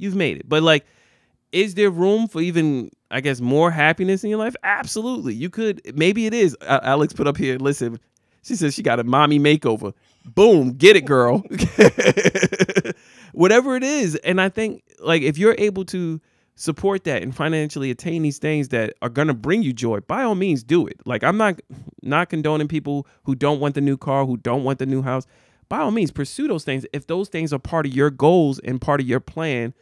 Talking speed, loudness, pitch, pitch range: 215 wpm, -19 LUFS, 150 Hz, 135-185 Hz